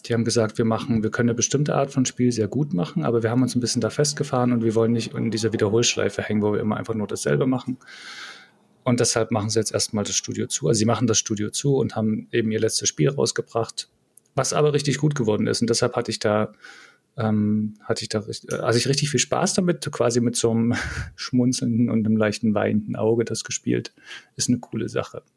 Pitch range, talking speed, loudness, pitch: 110-125 Hz, 220 wpm, -23 LUFS, 115 Hz